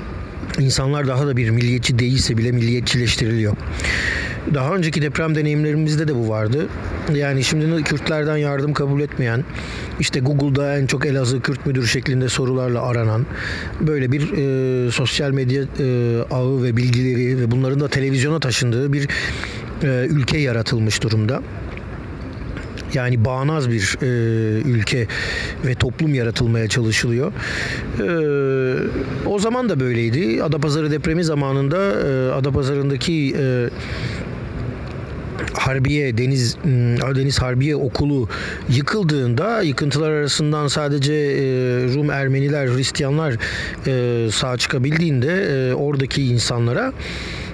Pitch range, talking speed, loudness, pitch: 120-145 Hz, 115 wpm, -19 LUFS, 130 Hz